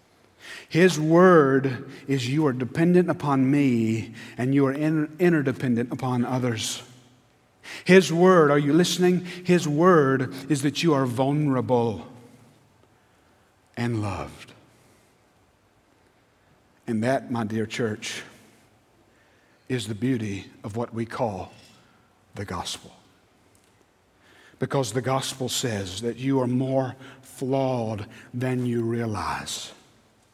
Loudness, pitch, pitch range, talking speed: -23 LUFS, 125 Hz, 115-135 Hz, 105 wpm